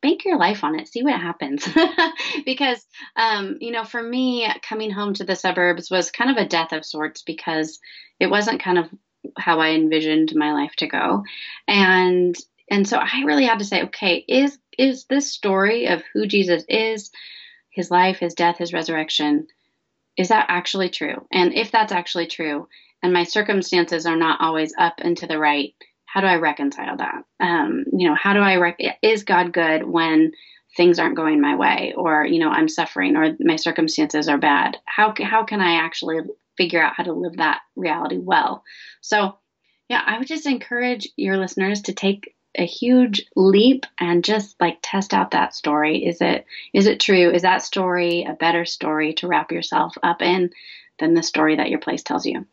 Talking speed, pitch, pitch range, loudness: 195 wpm, 185 Hz, 170-235 Hz, -20 LUFS